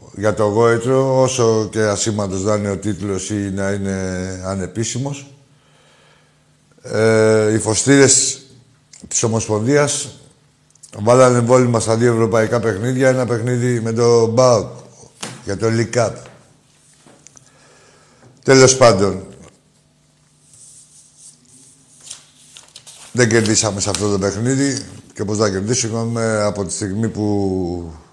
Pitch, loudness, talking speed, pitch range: 115 Hz, -16 LUFS, 105 wpm, 105-130 Hz